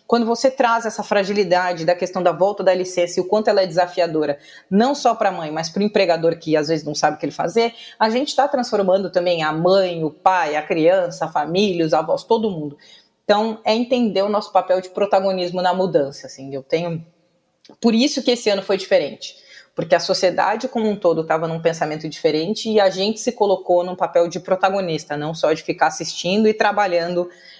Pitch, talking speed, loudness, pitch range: 185 Hz, 215 wpm, -19 LUFS, 170-210 Hz